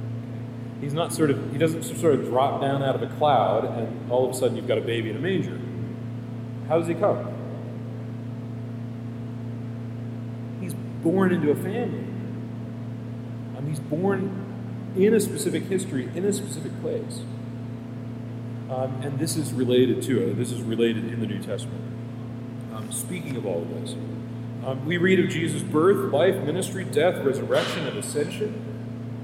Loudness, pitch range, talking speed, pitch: -26 LUFS, 115-125 Hz, 160 wpm, 120 Hz